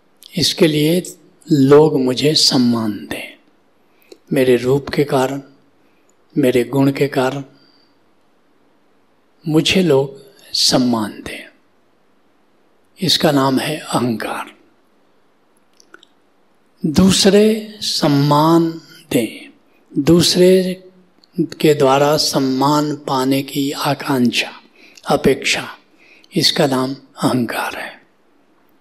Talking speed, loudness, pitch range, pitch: 75 wpm, -15 LUFS, 135-170 Hz, 150 Hz